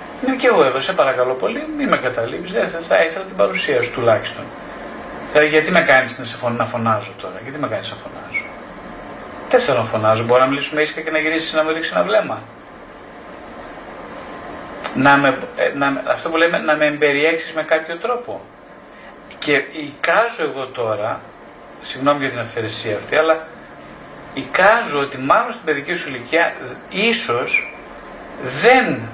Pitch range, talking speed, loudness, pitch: 130-165 Hz, 160 wpm, -17 LUFS, 150 Hz